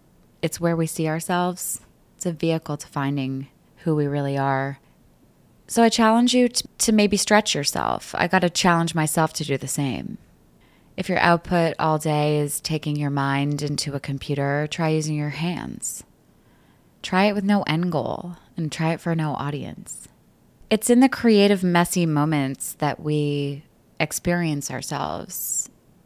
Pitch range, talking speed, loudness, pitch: 145-175 Hz, 160 wpm, -22 LUFS, 155 Hz